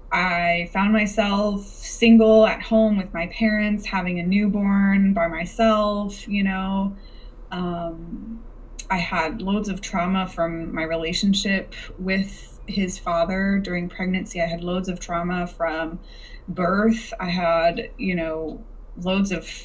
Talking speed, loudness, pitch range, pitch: 130 wpm, -22 LUFS, 175-205 Hz, 190 Hz